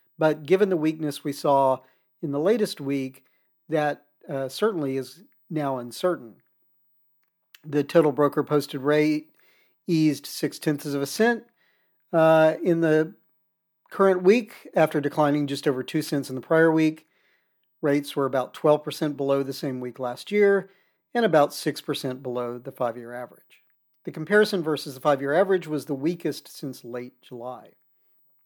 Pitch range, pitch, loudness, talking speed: 140-170 Hz, 150 Hz, -24 LUFS, 155 wpm